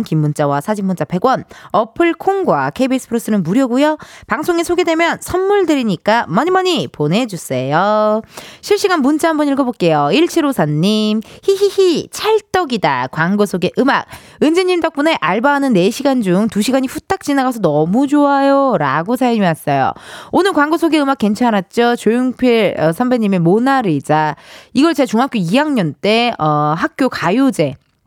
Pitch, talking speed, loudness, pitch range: 245 Hz, 310 characters per minute, -14 LUFS, 190-300 Hz